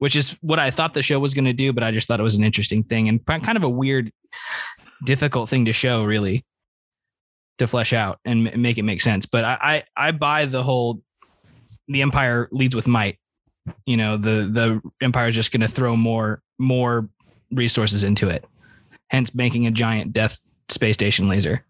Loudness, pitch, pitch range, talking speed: -20 LUFS, 120 Hz, 110-130 Hz, 200 wpm